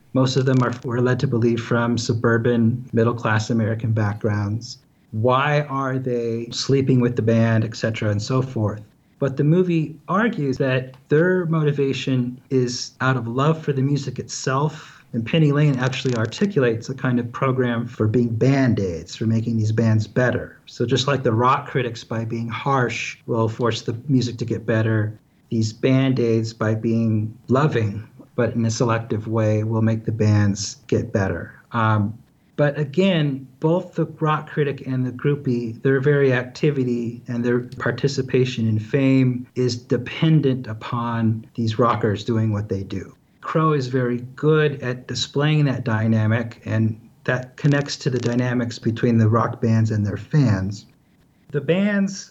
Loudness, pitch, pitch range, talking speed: -21 LUFS, 125 Hz, 115-135 Hz, 160 wpm